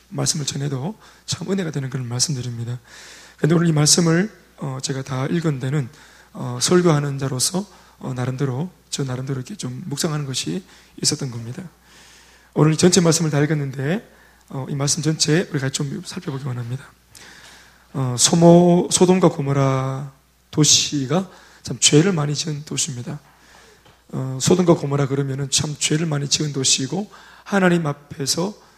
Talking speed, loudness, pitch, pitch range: 315 characters per minute, -19 LUFS, 145 Hz, 135-170 Hz